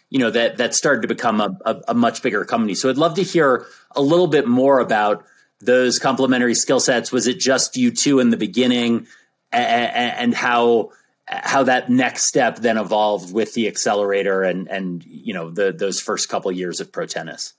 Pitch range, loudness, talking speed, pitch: 110-140 Hz, -18 LUFS, 205 wpm, 125 Hz